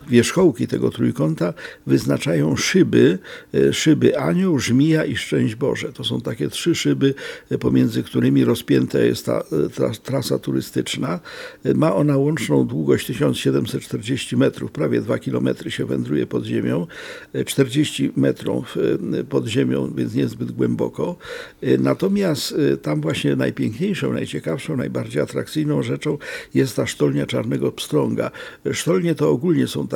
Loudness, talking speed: -20 LUFS, 120 wpm